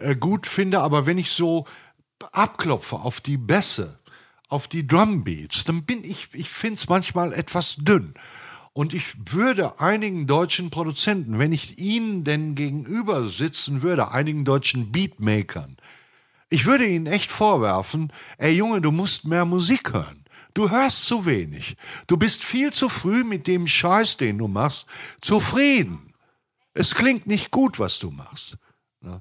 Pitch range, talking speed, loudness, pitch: 140-205 Hz, 150 wpm, -21 LUFS, 170 Hz